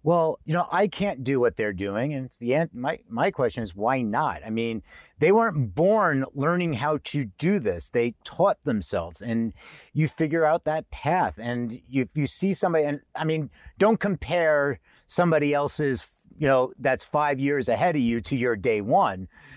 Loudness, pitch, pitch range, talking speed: -25 LUFS, 145 Hz, 125-160 Hz, 195 wpm